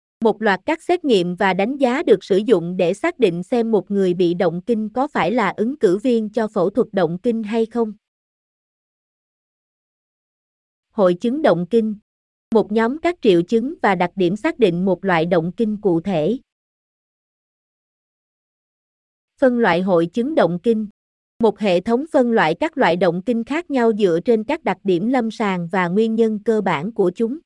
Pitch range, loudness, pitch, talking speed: 185-240 Hz, -19 LUFS, 220 Hz, 185 wpm